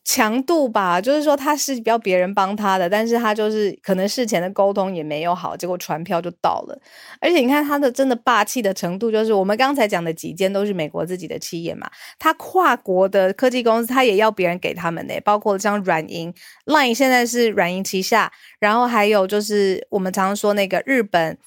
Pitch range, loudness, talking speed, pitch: 185-245 Hz, -19 LUFS, 335 characters per minute, 205 Hz